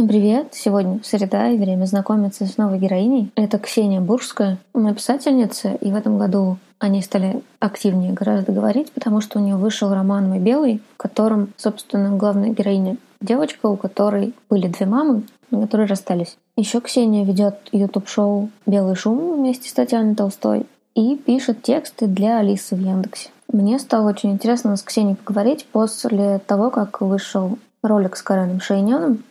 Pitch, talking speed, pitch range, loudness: 210 Hz, 155 wpm, 200-235 Hz, -19 LUFS